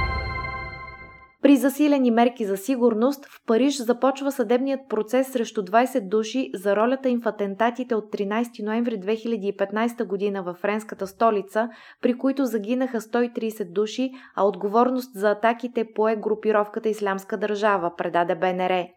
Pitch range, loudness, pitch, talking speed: 205-245 Hz, -24 LUFS, 220 Hz, 130 wpm